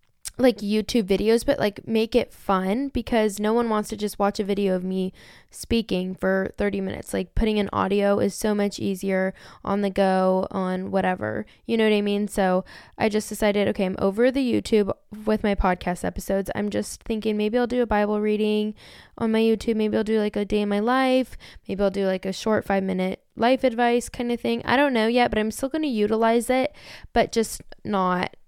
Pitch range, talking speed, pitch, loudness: 195-225 Hz, 215 wpm, 210 Hz, -24 LUFS